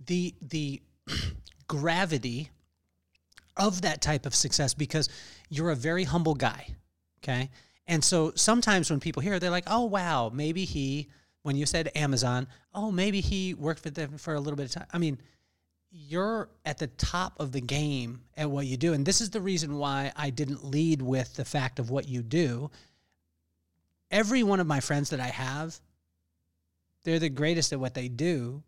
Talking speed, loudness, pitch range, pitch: 180 wpm, -29 LUFS, 130-165 Hz, 150 Hz